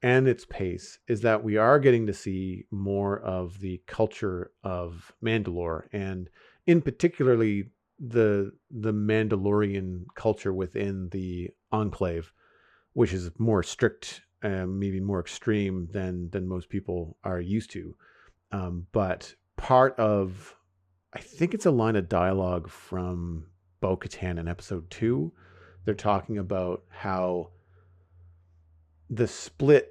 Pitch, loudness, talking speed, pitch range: 95 Hz, -28 LUFS, 125 wpm, 90-110 Hz